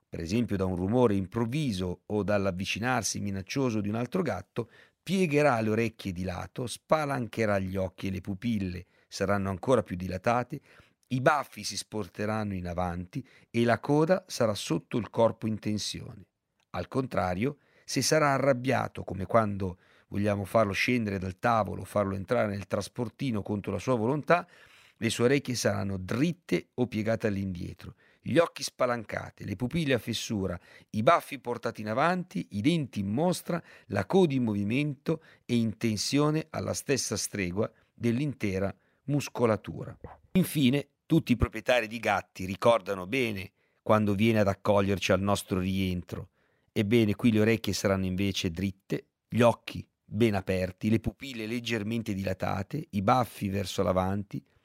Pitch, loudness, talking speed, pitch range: 110 Hz, -29 LUFS, 145 wpm, 95-125 Hz